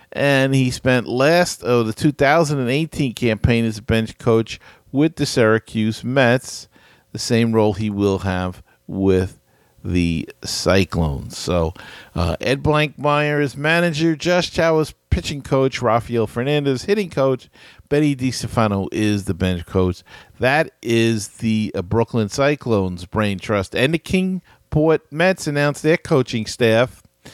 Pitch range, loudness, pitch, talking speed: 105-145 Hz, -19 LUFS, 120 Hz, 135 wpm